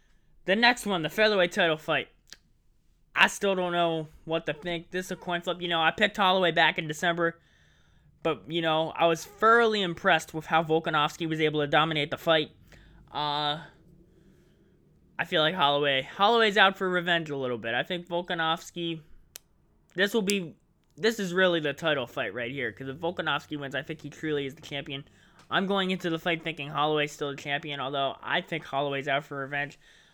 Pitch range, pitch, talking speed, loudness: 145-180 Hz, 160 Hz, 195 wpm, -27 LUFS